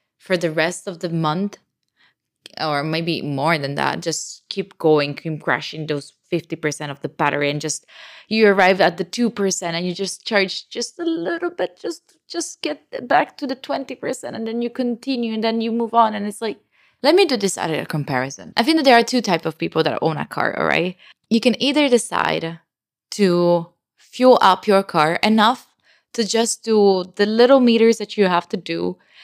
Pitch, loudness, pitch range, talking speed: 195 Hz, -19 LUFS, 165-235 Hz, 200 wpm